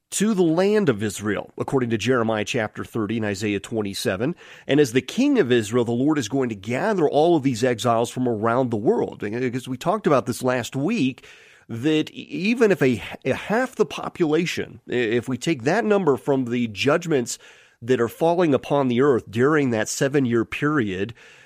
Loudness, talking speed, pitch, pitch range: -22 LUFS, 185 wpm, 130 Hz, 115-150 Hz